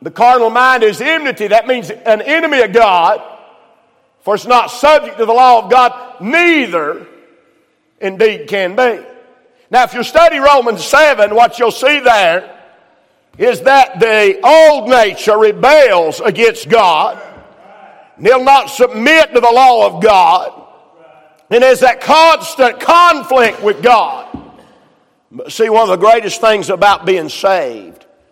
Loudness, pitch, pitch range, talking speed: -9 LUFS, 245 Hz, 220-275 Hz, 140 wpm